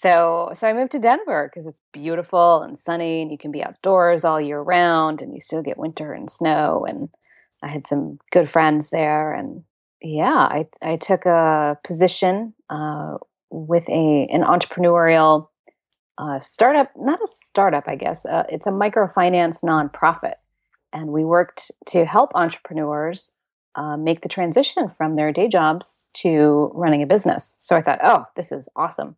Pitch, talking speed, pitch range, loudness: 165 Hz, 170 wpm, 155-180 Hz, -19 LUFS